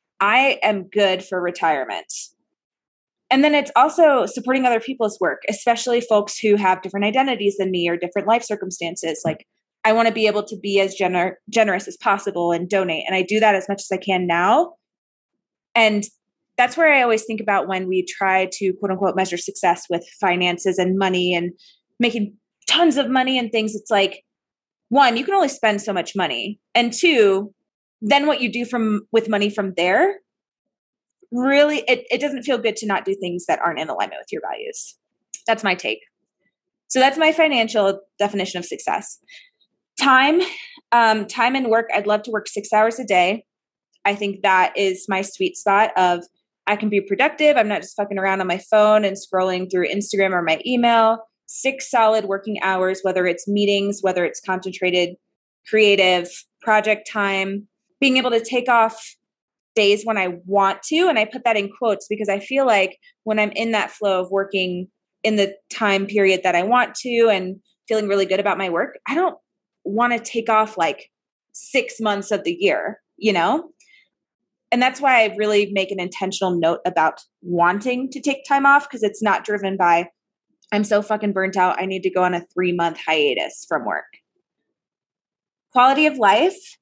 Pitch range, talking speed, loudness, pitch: 190-240 Hz, 190 wpm, -19 LUFS, 205 Hz